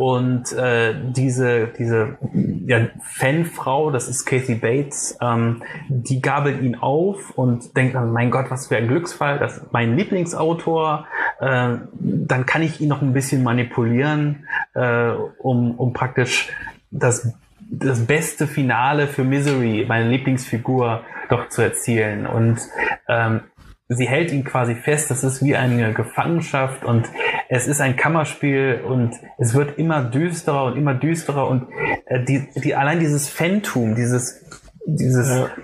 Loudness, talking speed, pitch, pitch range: -20 LUFS, 145 wpm, 130 Hz, 120-145 Hz